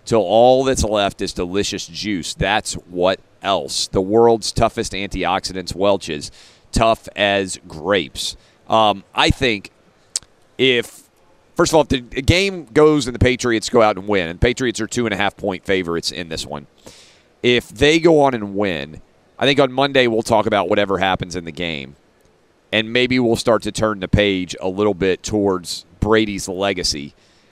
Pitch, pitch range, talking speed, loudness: 105 Hz, 95-120 Hz, 175 wpm, -18 LUFS